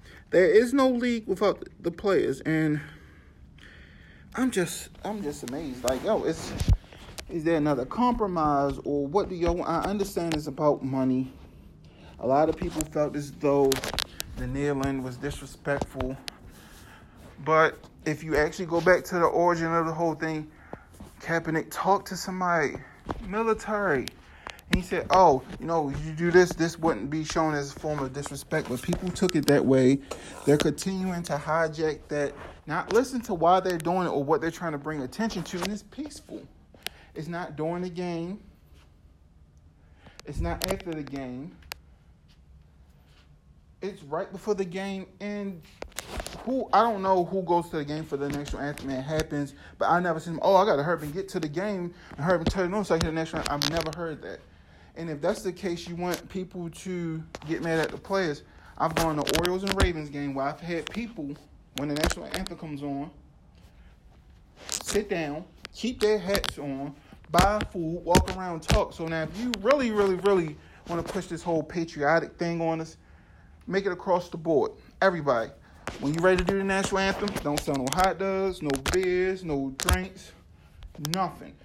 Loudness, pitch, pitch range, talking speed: -27 LUFS, 160 Hz, 140-185 Hz, 185 wpm